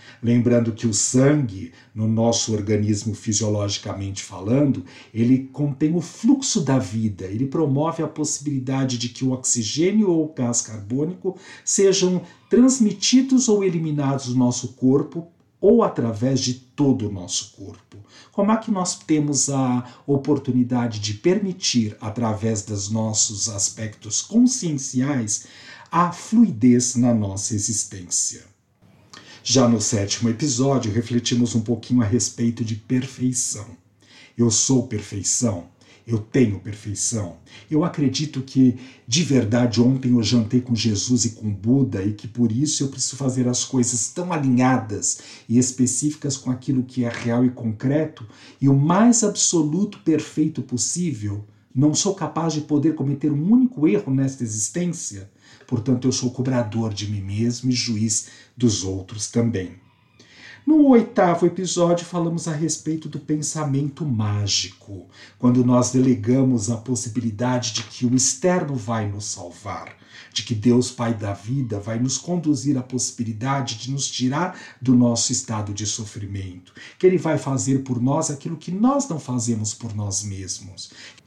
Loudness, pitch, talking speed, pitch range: -21 LUFS, 125 Hz, 145 wpm, 110-145 Hz